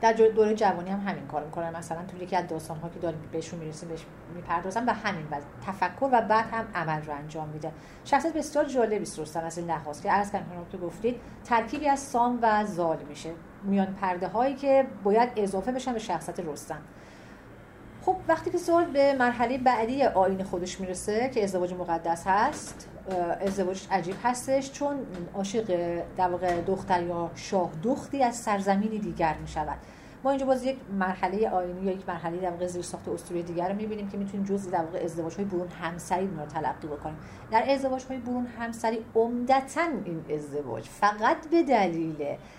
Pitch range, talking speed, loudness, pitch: 170-235 Hz, 175 wpm, -28 LUFS, 190 Hz